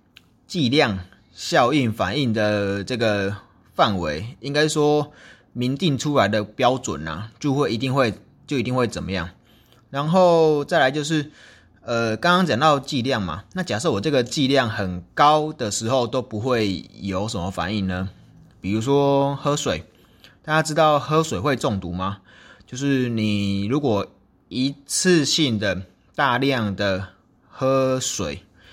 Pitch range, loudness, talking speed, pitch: 100-140 Hz, -21 LUFS, 205 characters per minute, 120 Hz